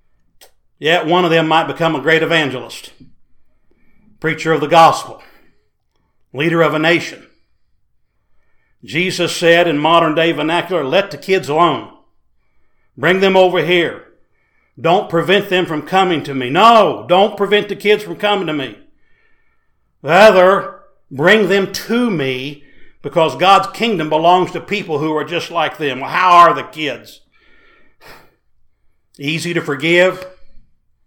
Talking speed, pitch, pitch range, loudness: 135 wpm, 170 Hz, 150-190 Hz, -14 LUFS